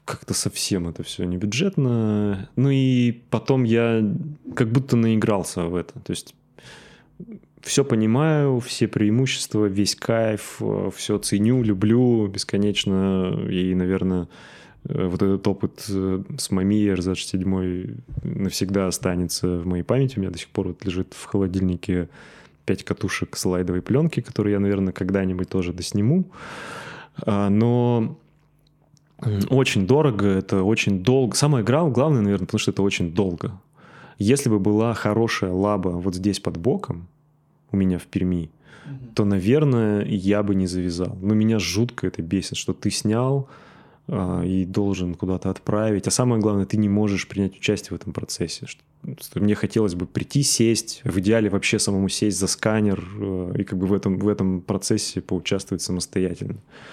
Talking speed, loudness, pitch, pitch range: 145 wpm, -22 LUFS, 105 Hz, 95-120 Hz